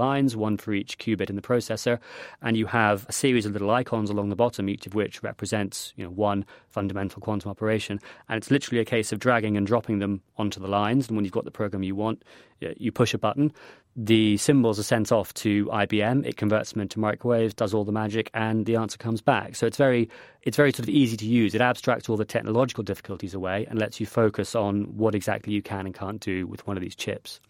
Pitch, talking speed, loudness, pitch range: 110 Hz, 240 wpm, -26 LUFS, 100-115 Hz